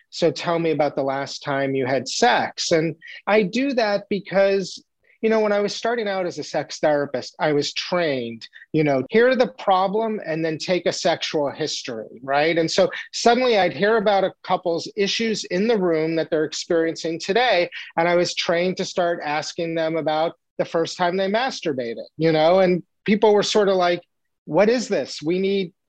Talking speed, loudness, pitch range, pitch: 195 wpm, -21 LUFS, 155-195 Hz, 175 Hz